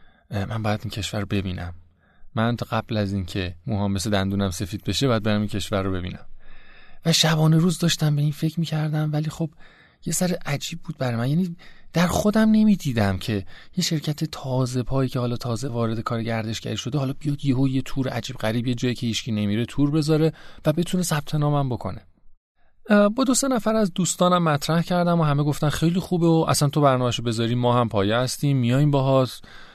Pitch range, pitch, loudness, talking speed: 110-160 Hz, 135 Hz, -23 LUFS, 200 wpm